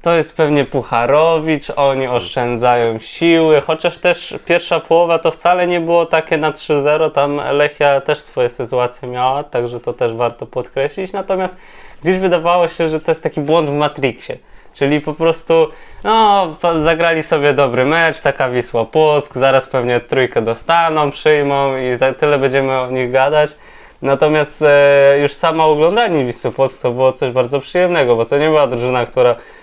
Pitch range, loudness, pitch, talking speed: 130-165 Hz, -14 LUFS, 150 Hz, 160 wpm